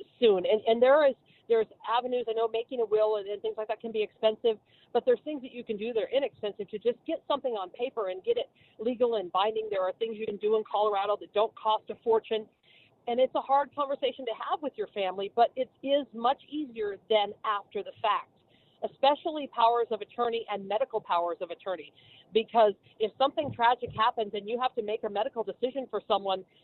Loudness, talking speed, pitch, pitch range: -29 LUFS, 220 wpm, 225 Hz, 210-250 Hz